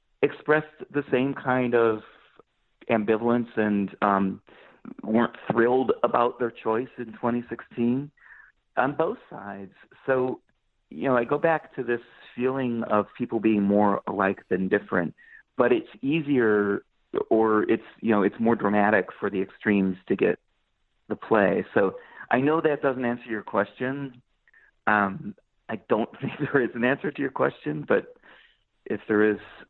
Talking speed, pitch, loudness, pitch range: 150 wpm, 120 Hz, -25 LUFS, 105-130 Hz